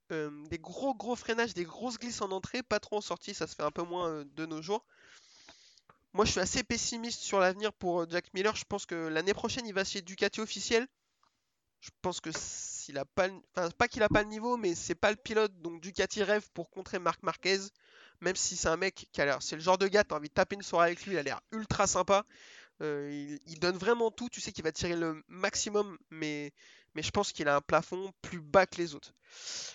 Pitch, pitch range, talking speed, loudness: 190 Hz, 170-215 Hz, 245 wpm, -33 LUFS